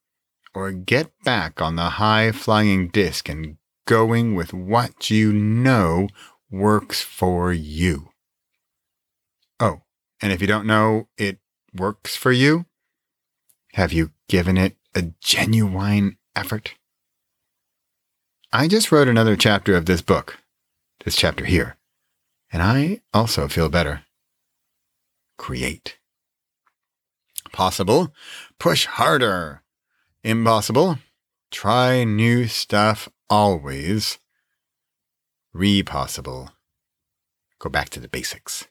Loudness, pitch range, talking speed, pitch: -20 LUFS, 85-110 Hz, 100 wpm, 100 Hz